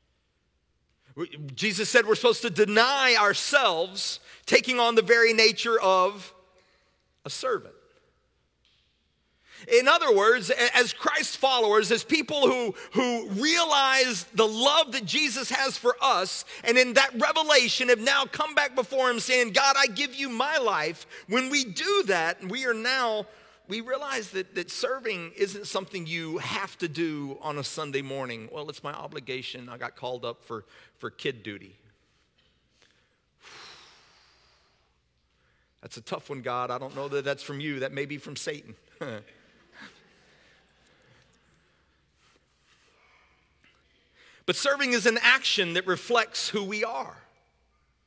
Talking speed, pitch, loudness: 140 wpm, 215 Hz, -24 LUFS